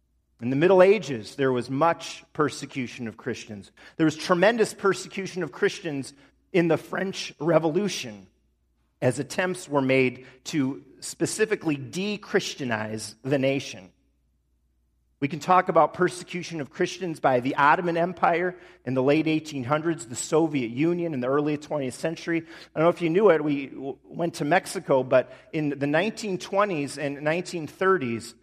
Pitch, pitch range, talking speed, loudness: 155 Hz, 130-180 Hz, 150 wpm, -25 LUFS